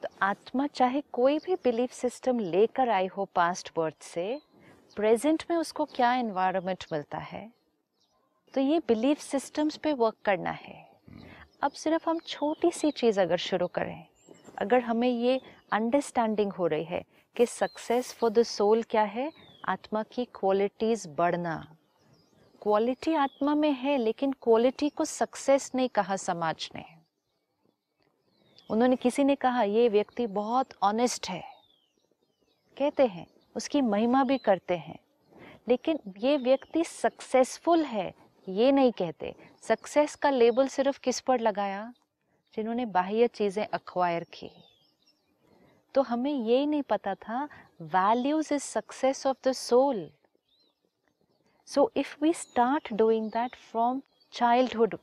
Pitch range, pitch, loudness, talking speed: 205-275 Hz, 240 Hz, -28 LUFS, 135 wpm